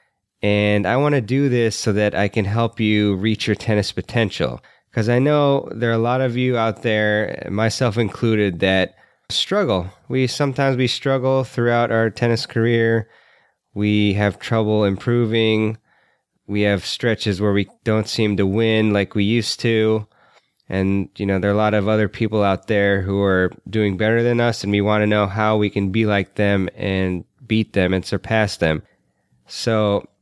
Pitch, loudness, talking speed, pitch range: 110 Hz, -19 LUFS, 185 wpm, 100-115 Hz